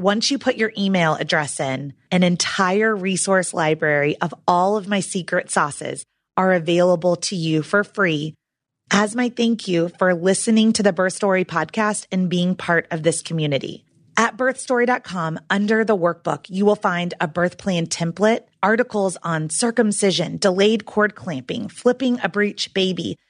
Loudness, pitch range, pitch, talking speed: -20 LUFS, 170-210 Hz, 185 Hz, 160 wpm